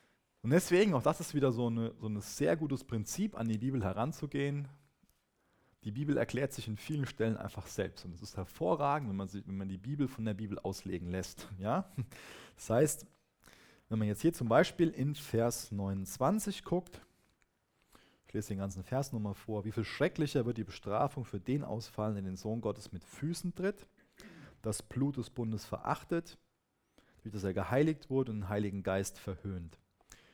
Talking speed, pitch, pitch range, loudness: 180 wpm, 115 Hz, 100-145 Hz, -36 LUFS